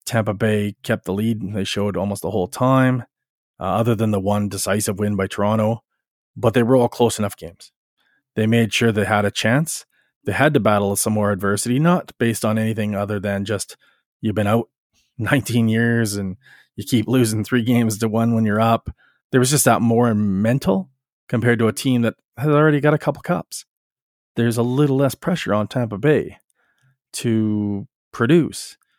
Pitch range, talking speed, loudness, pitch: 105-125 Hz, 190 wpm, -19 LUFS, 115 Hz